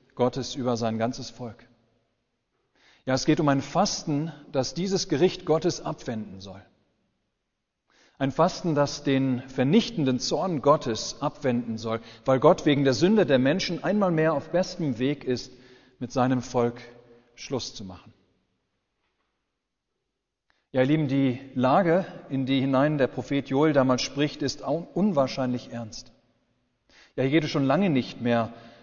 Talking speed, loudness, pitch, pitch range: 145 wpm, -25 LUFS, 130 Hz, 120-150 Hz